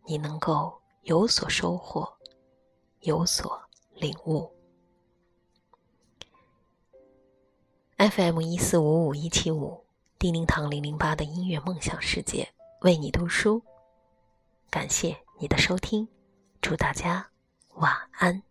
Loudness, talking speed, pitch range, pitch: -27 LUFS, 155 characters per minute, 130-175 Hz, 155 Hz